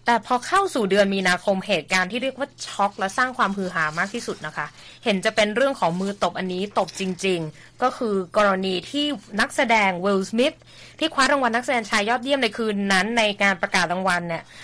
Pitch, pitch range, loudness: 205 Hz, 185-240 Hz, -22 LUFS